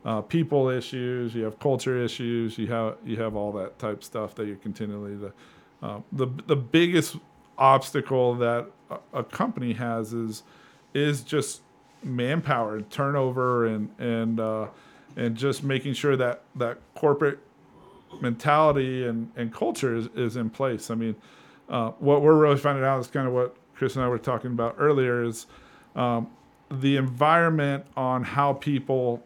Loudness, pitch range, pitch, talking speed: -26 LUFS, 115-140 Hz, 125 Hz, 160 wpm